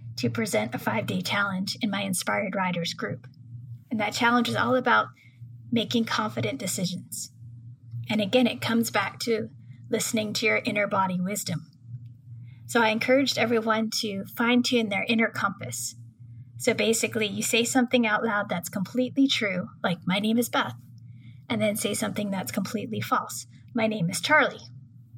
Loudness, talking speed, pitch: -26 LUFS, 155 wpm, 200 Hz